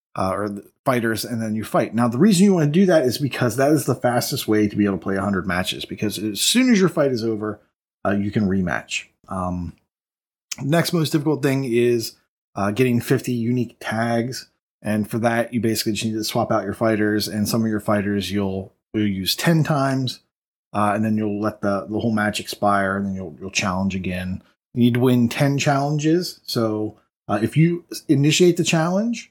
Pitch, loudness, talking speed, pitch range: 115 Hz, -21 LUFS, 215 wpm, 105-135 Hz